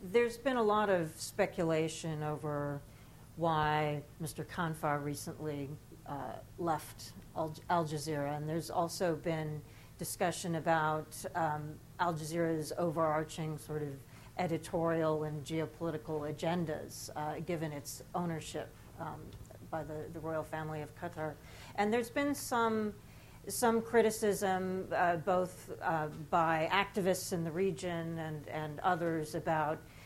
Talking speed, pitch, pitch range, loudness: 125 wpm, 160 Hz, 150-175 Hz, -36 LUFS